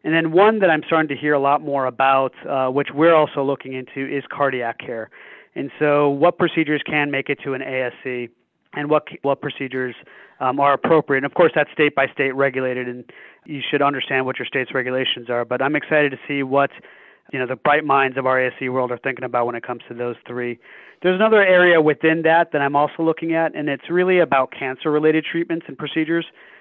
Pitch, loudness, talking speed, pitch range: 140 Hz, -19 LUFS, 215 wpm, 130-155 Hz